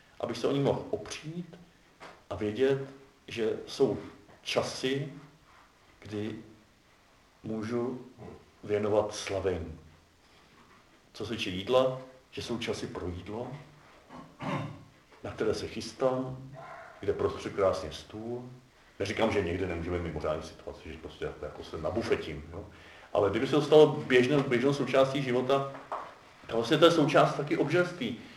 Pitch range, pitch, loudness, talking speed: 95-135 Hz, 120 Hz, -30 LUFS, 125 wpm